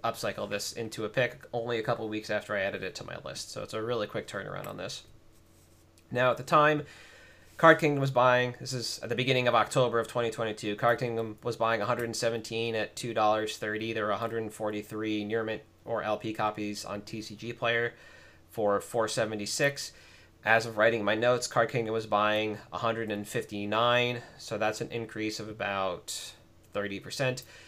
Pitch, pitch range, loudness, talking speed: 110 Hz, 105-120 Hz, -30 LUFS, 170 wpm